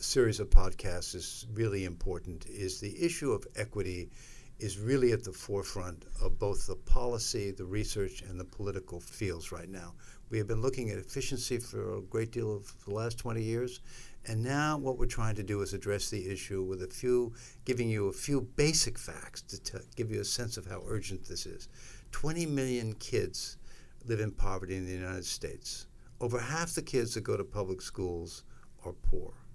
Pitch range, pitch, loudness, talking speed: 95-120 Hz, 105 Hz, -35 LUFS, 195 wpm